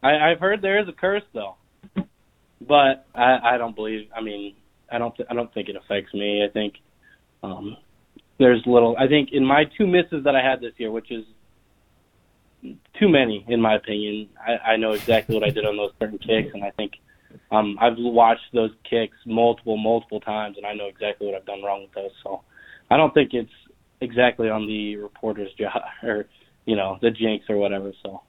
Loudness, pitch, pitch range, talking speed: -22 LUFS, 110 Hz, 105-125 Hz, 205 wpm